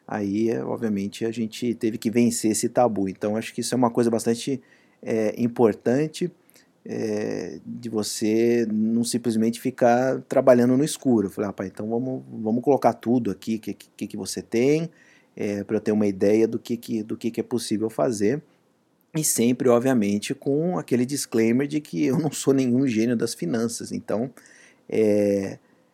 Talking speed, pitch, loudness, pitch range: 165 wpm, 115 Hz, -24 LUFS, 110-125 Hz